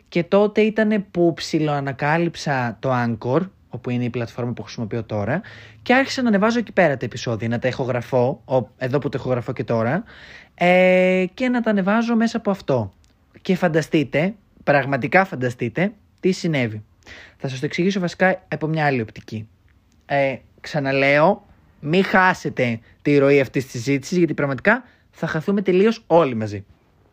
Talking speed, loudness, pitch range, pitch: 155 wpm, -20 LUFS, 125-185 Hz, 145 Hz